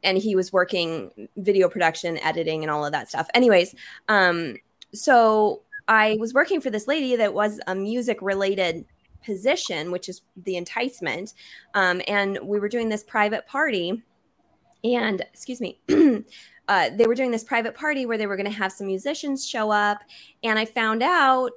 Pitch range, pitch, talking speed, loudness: 185-240 Hz, 210 Hz, 175 wpm, -23 LUFS